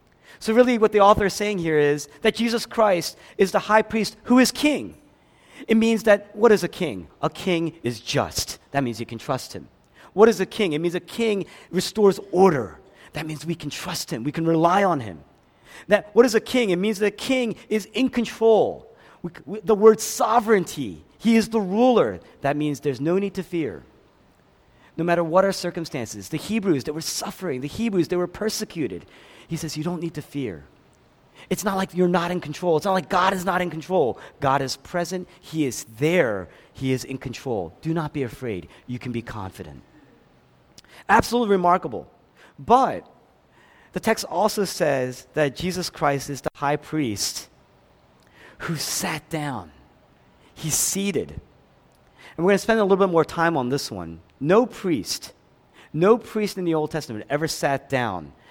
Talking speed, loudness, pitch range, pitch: 190 wpm, -22 LUFS, 145-205 Hz, 175 Hz